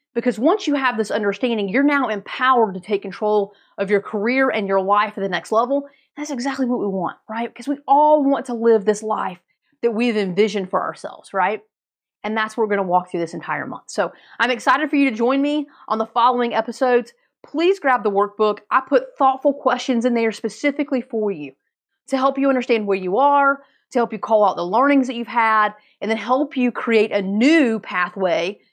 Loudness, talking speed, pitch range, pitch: -19 LUFS, 215 wpm, 210-270 Hz, 235 Hz